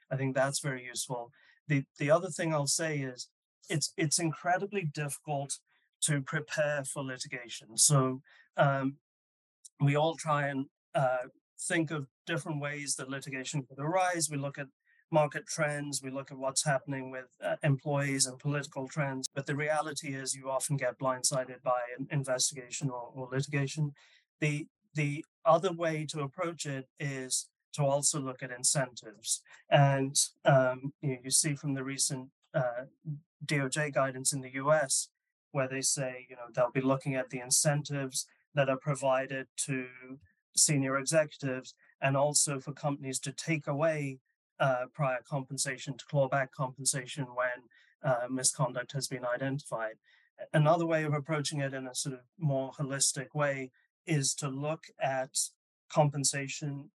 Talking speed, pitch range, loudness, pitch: 155 wpm, 130-150 Hz, -32 LUFS, 140 Hz